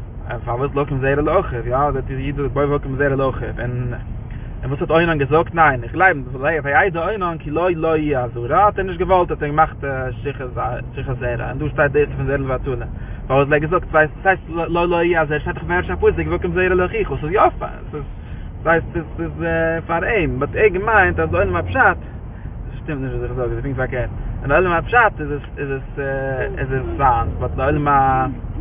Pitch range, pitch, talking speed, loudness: 125-160 Hz, 140 Hz, 225 wpm, -19 LUFS